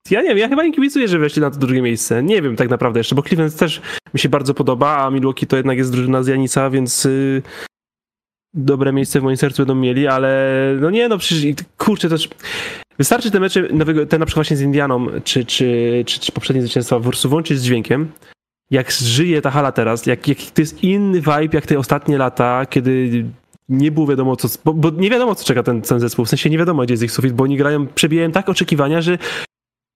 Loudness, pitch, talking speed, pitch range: -16 LUFS, 140 Hz, 230 wpm, 130-160 Hz